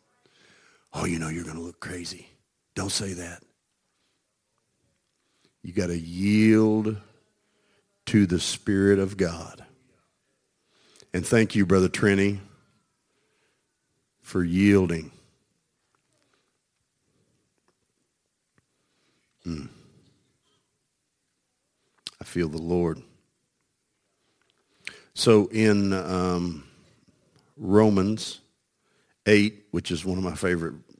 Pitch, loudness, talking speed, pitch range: 95 Hz, -24 LUFS, 85 wpm, 90-105 Hz